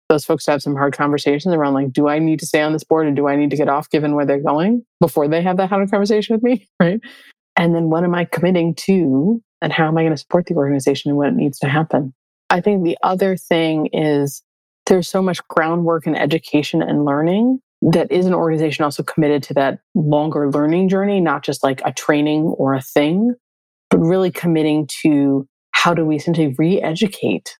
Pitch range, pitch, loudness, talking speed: 145-180 Hz, 160 Hz, -17 LUFS, 220 wpm